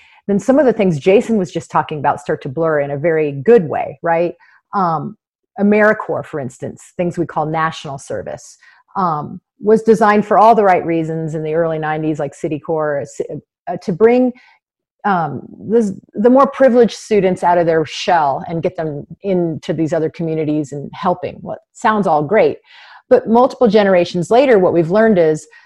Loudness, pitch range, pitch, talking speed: -15 LUFS, 160-220 Hz, 175 Hz, 180 wpm